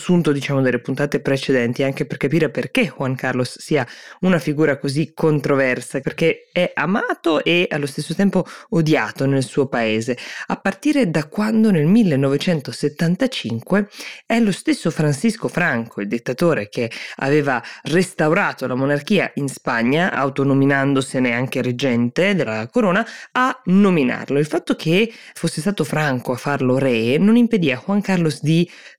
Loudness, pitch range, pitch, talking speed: -19 LUFS, 135-185 Hz, 150 Hz, 145 wpm